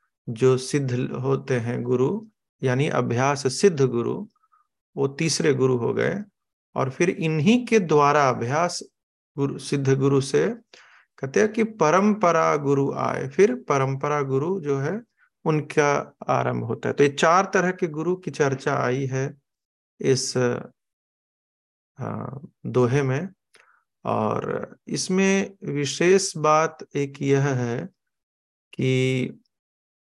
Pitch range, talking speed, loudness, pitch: 130-185 Hz, 120 wpm, -23 LUFS, 145 Hz